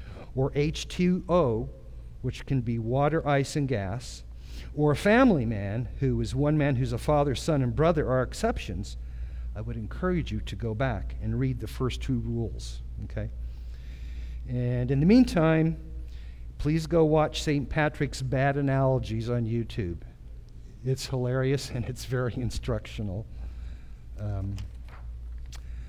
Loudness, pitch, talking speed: -28 LUFS, 120 Hz, 135 wpm